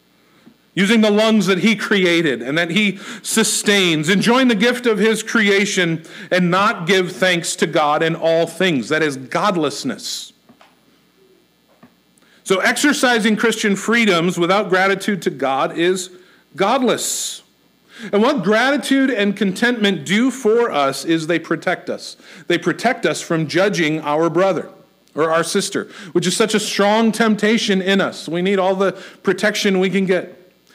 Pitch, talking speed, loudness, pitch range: 195 Hz, 150 wpm, -17 LUFS, 175-215 Hz